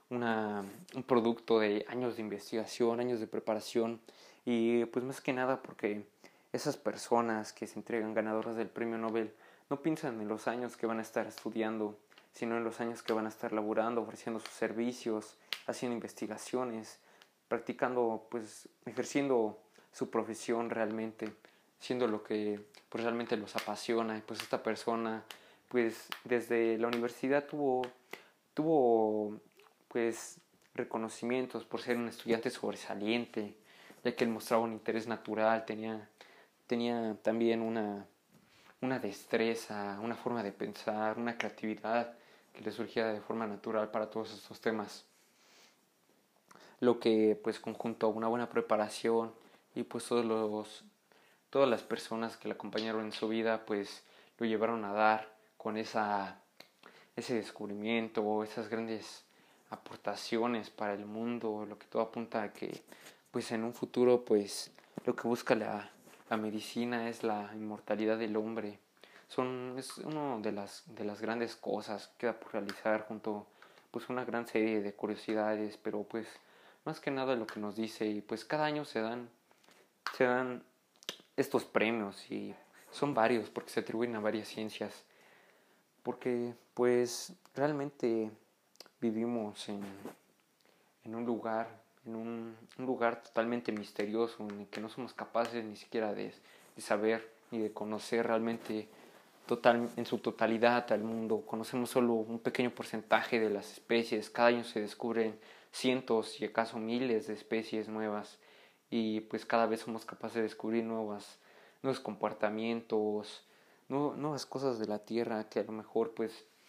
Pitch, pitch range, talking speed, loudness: 115 Hz, 110-120 Hz, 150 wpm, -36 LUFS